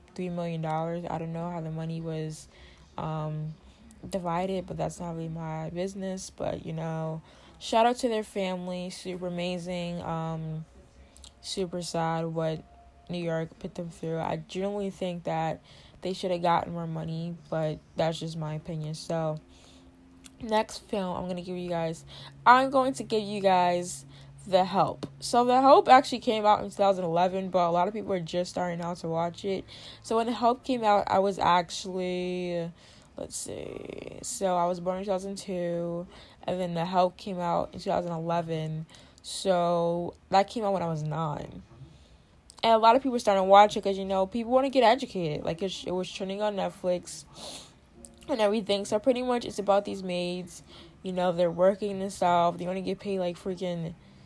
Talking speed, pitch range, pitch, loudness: 180 wpm, 165-195 Hz, 180 Hz, -28 LUFS